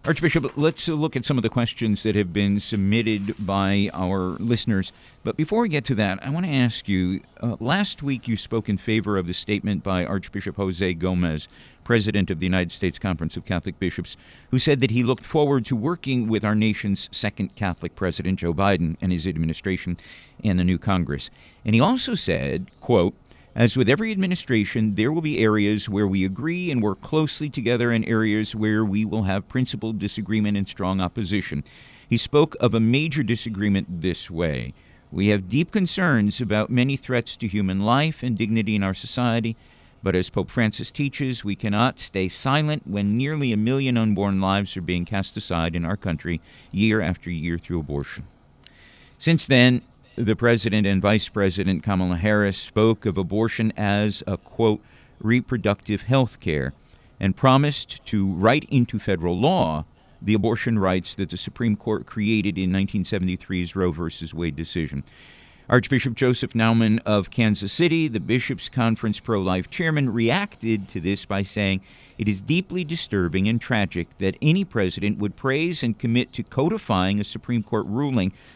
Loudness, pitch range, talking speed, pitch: -23 LUFS, 95-125 Hz, 175 wpm, 105 Hz